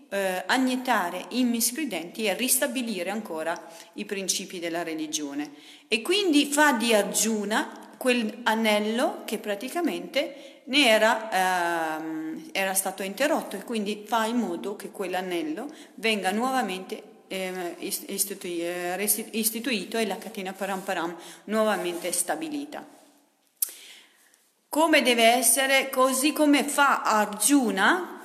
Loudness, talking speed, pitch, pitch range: -25 LUFS, 110 wpm, 220 Hz, 190-265 Hz